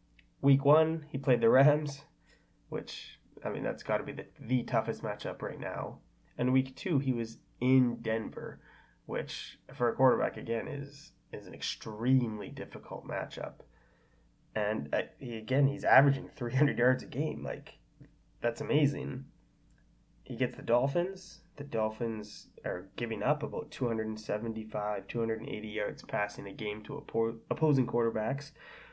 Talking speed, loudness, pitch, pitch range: 145 wpm, -32 LUFS, 125 Hz, 115-140 Hz